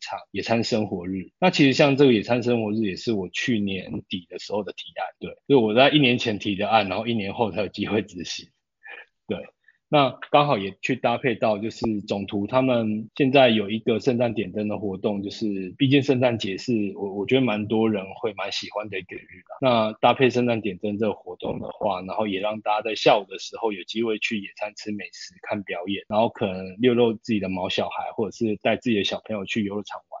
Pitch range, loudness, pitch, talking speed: 100-120 Hz, -24 LUFS, 110 Hz, 325 characters per minute